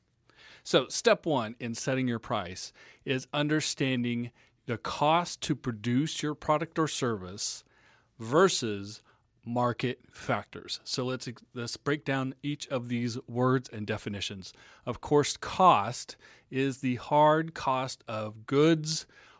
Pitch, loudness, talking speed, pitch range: 130 Hz, -30 LUFS, 125 wpm, 120-150 Hz